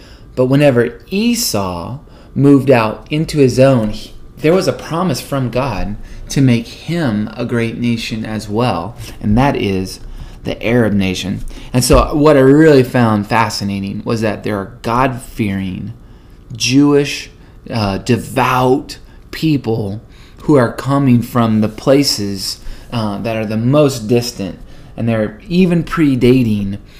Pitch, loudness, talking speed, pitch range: 120 Hz, -14 LUFS, 140 wpm, 105-135 Hz